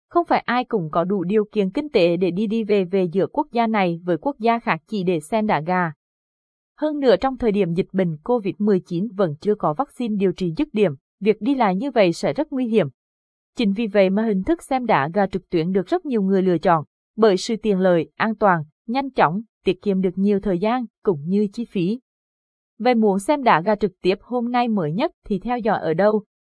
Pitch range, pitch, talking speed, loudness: 185-230 Hz, 205 Hz, 235 wpm, -21 LUFS